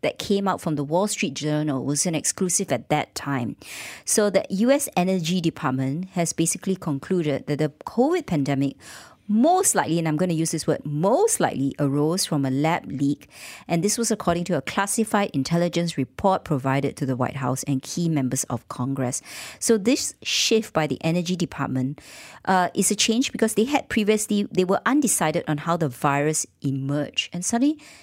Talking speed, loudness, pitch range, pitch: 185 wpm, -23 LUFS, 145-200 Hz, 170 Hz